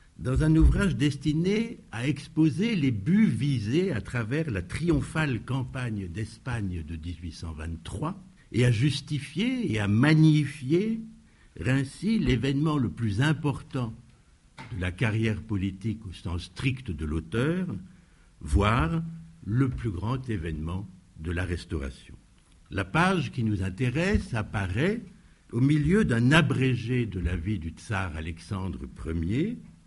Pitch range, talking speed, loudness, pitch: 95-155 Hz, 125 wpm, -28 LUFS, 125 Hz